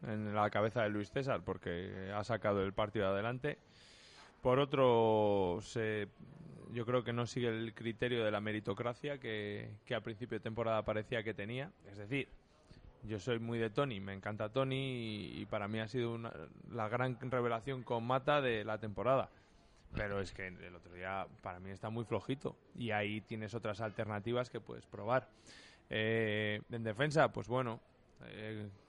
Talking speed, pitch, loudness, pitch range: 175 wpm, 110 Hz, -38 LUFS, 105-120 Hz